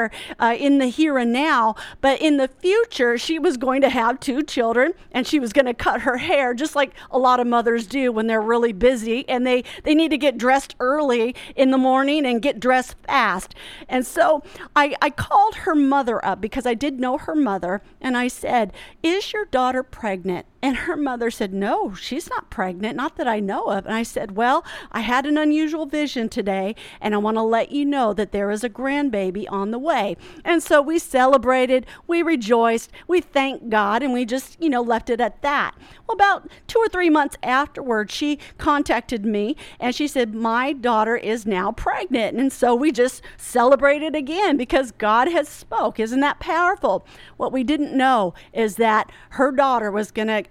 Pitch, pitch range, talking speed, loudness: 255 Hz, 230-295 Hz, 200 wpm, -20 LUFS